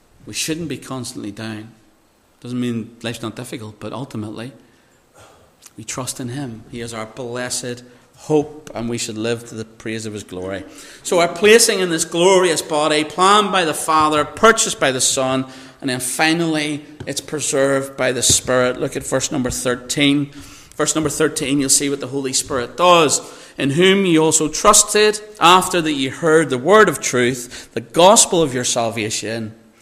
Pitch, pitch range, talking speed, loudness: 135 Hz, 120-155 Hz, 175 wpm, -16 LUFS